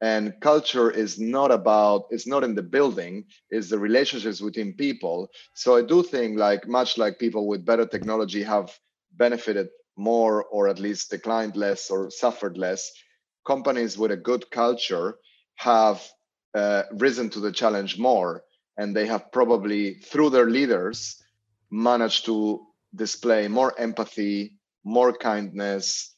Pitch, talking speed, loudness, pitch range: 110 Hz, 145 wpm, -24 LUFS, 105-120 Hz